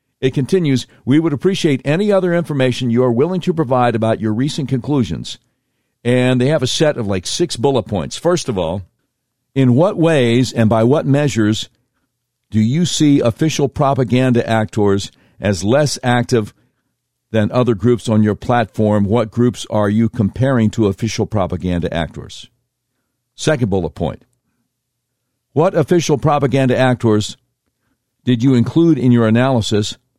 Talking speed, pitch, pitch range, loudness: 145 wpm, 125 Hz, 110-135 Hz, -16 LUFS